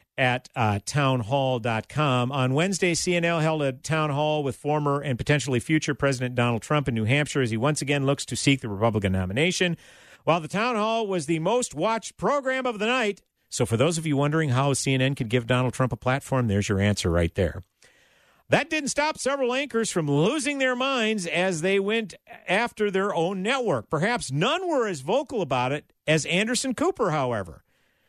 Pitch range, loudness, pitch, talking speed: 130-200 Hz, -25 LUFS, 150 Hz, 190 wpm